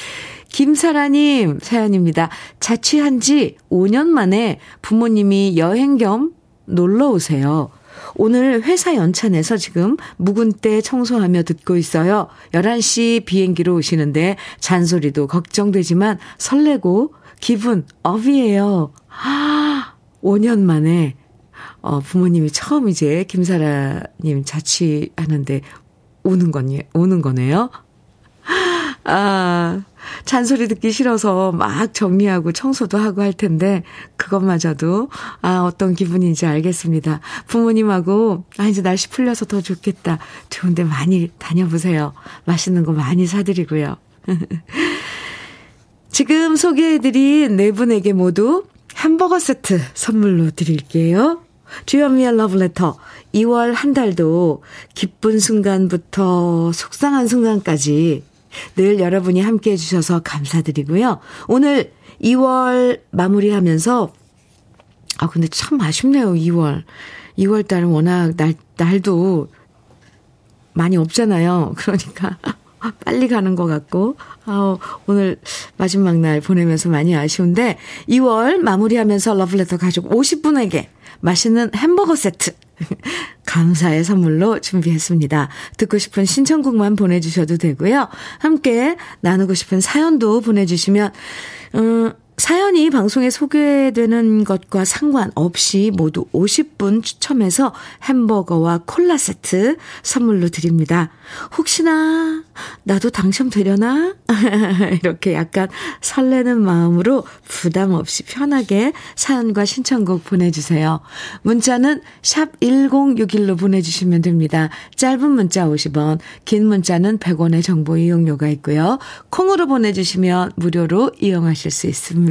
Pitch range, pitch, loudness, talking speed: 170-235 Hz, 195 Hz, -16 LUFS, 255 characters per minute